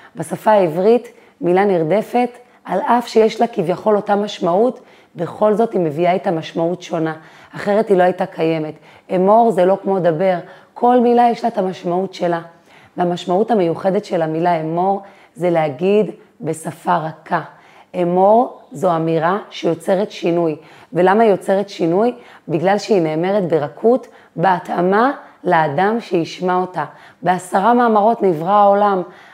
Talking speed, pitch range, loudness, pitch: 135 wpm, 170-210 Hz, -17 LUFS, 185 Hz